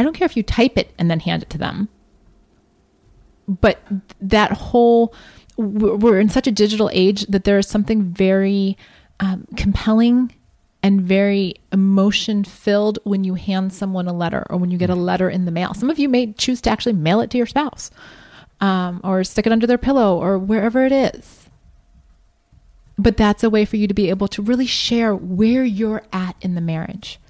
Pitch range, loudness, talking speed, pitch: 190-230 Hz, -18 LUFS, 195 wpm, 205 Hz